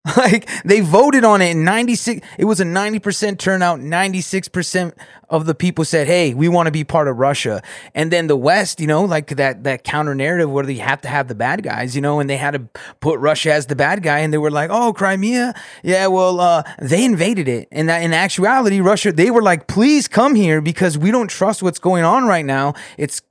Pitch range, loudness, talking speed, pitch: 150-195 Hz, -16 LUFS, 230 wpm, 175 Hz